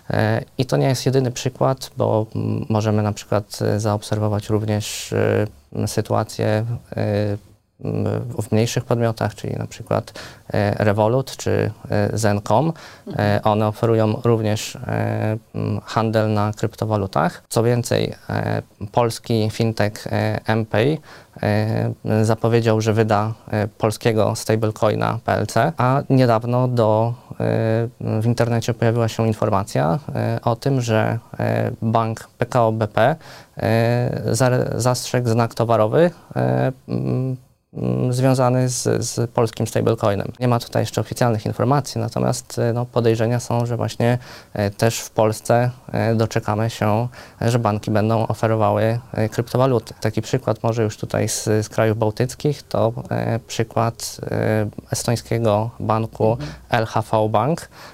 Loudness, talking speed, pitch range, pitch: -20 LUFS, 105 wpm, 105-120 Hz, 115 Hz